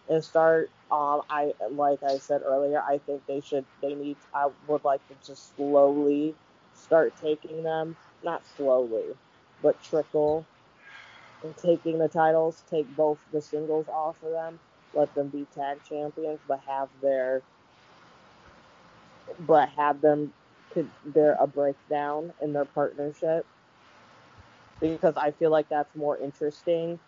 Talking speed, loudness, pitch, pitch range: 135 wpm, -27 LUFS, 150 Hz, 140-155 Hz